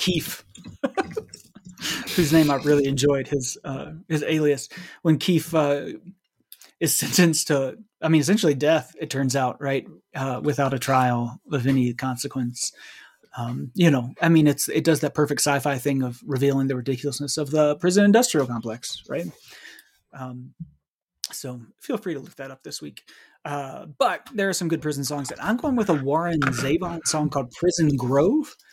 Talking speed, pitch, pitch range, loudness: 170 wpm, 145 Hz, 135-165 Hz, -23 LUFS